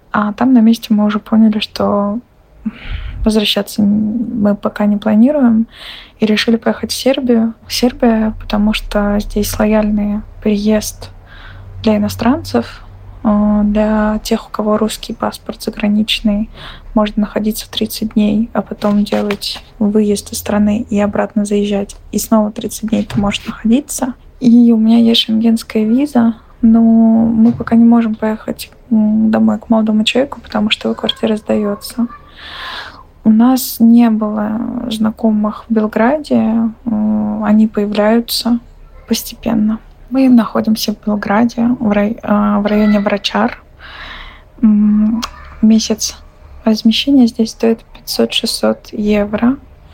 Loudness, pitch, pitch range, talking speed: -13 LUFS, 220 Hz, 210-230 Hz, 120 wpm